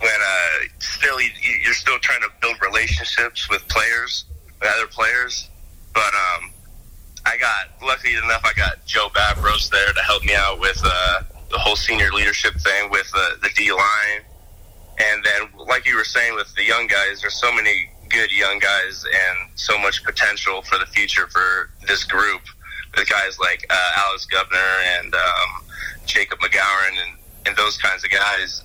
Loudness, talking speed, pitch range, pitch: -18 LUFS, 175 wpm, 80-105 Hz, 85 Hz